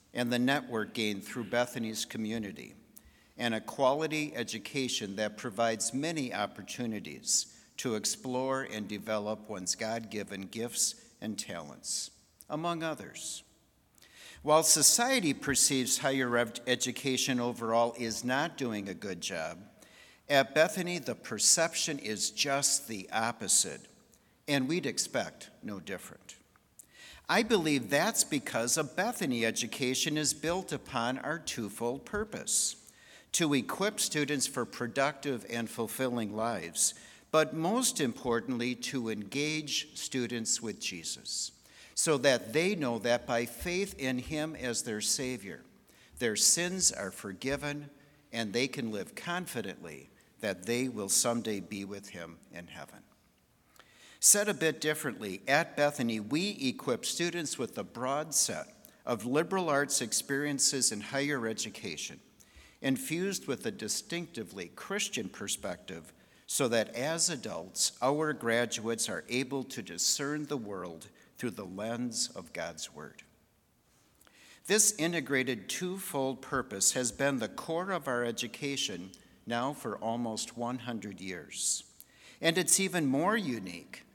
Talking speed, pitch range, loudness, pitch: 125 wpm, 115-155 Hz, -31 LUFS, 130 Hz